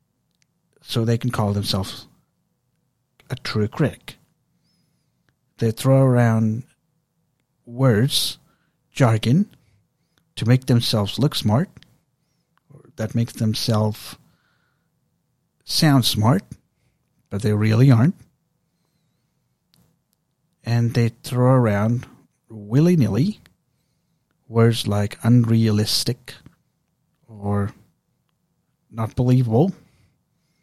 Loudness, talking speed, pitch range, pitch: -20 LUFS, 80 wpm, 115-155 Hz, 130 Hz